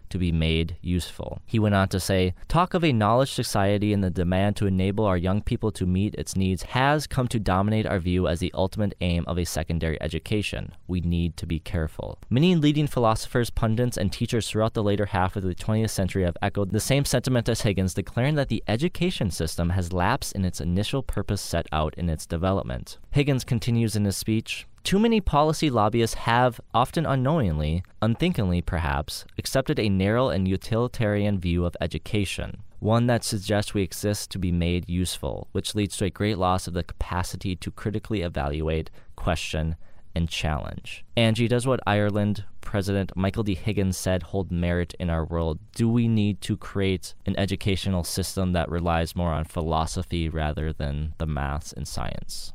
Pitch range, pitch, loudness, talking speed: 85-110 Hz, 95 Hz, -25 LUFS, 185 wpm